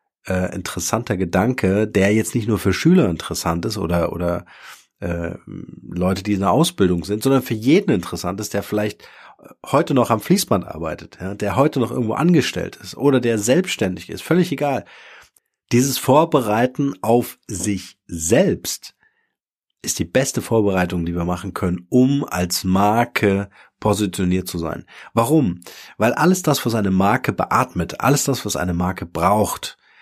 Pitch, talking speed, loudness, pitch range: 105 Hz, 155 wpm, -19 LUFS, 90-125 Hz